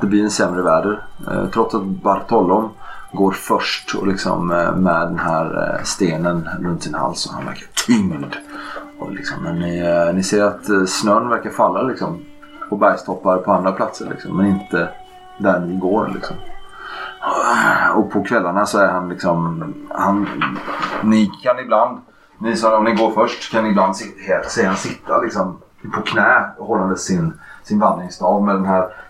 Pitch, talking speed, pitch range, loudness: 95 Hz, 160 wpm, 90-105 Hz, -18 LUFS